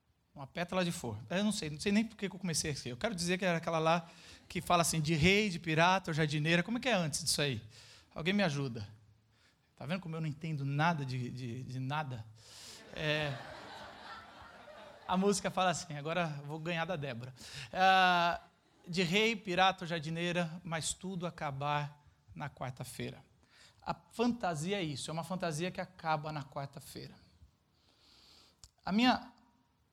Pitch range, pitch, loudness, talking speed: 145-185 Hz, 165 Hz, -34 LUFS, 170 wpm